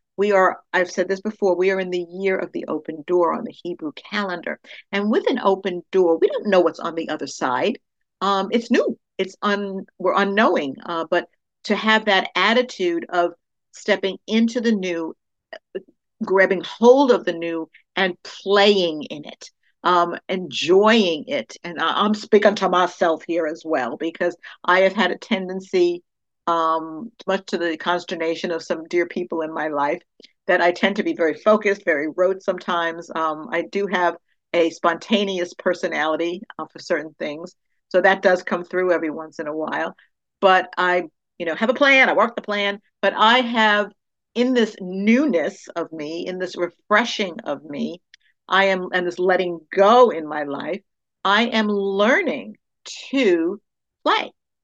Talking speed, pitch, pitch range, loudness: 175 wpm, 185 Hz, 170-205 Hz, -20 LUFS